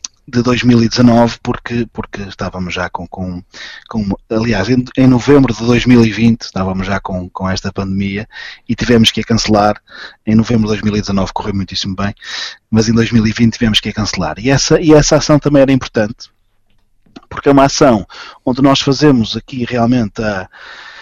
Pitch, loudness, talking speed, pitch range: 115 Hz, -13 LUFS, 165 wpm, 100-125 Hz